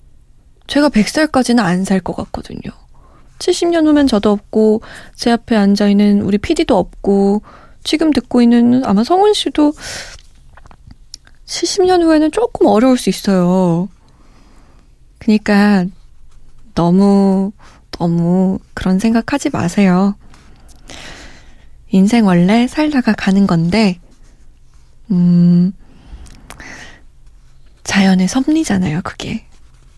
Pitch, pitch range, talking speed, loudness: 205 Hz, 185-260 Hz, 195 characters per minute, -13 LUFS